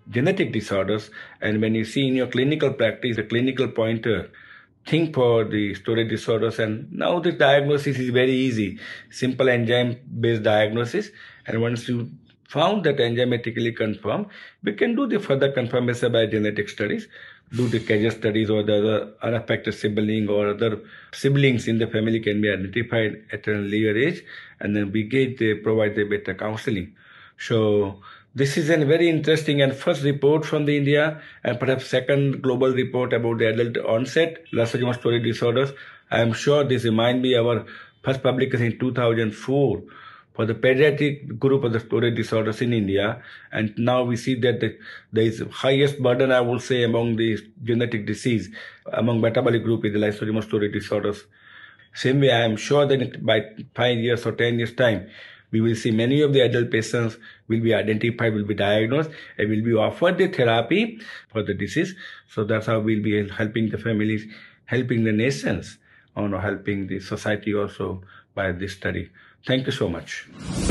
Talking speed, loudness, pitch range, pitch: 175 wpm, -22 LUFS, 110-130 Hz, 115 Hz